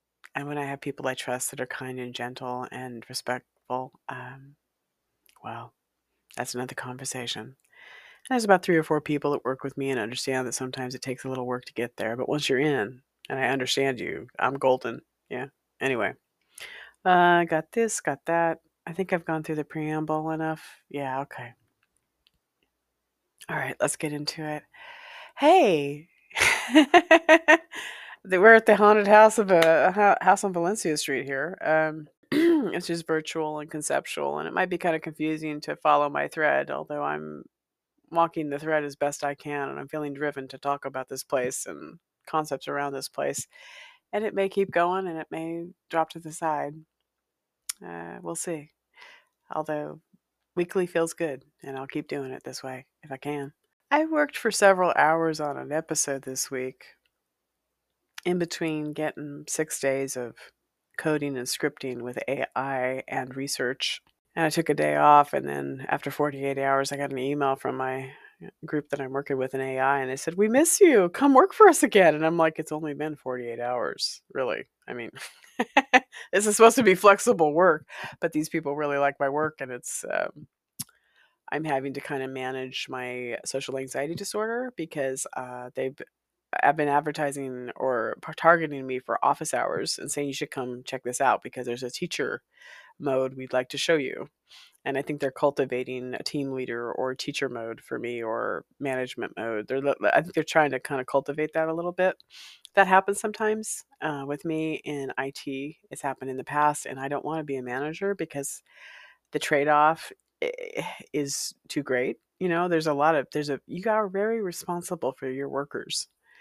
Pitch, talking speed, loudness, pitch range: 145 Hz, 185 wpm, -26 LUFS, 130-170 Hz